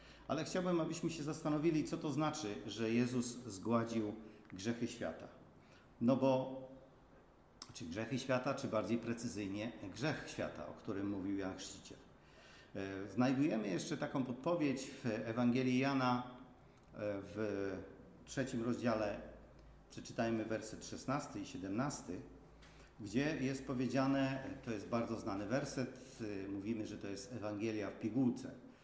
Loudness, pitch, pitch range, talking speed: -40 LUFS, 120 Hz, 110-135 Hz, 120 wpm